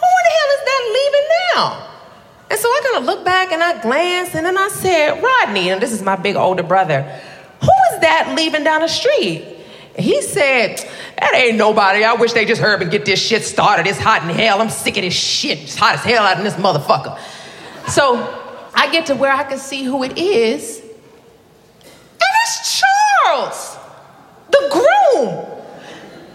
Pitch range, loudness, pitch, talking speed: 235-385 Hz, -14 LUFS, 320 Hz, 195 wpm